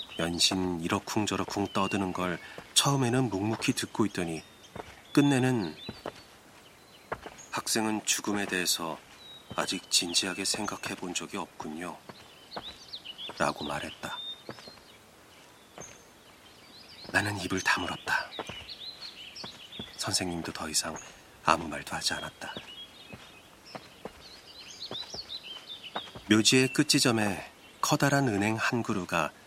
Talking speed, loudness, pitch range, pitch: 195 characters per minute, -29 LUFS, 90-120 Hz, 100 Hz